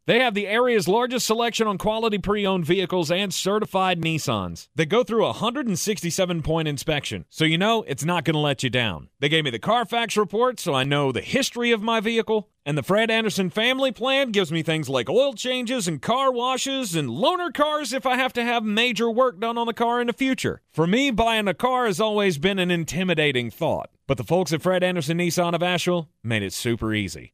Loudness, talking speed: -22 LUFS, 220 wpm